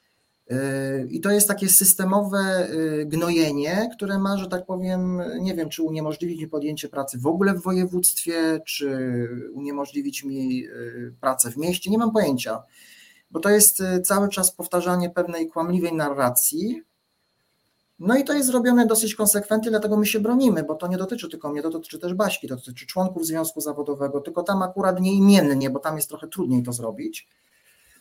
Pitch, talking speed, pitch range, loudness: 180 Hz, 165 wpm, 150-200 Hz, -22 LUFS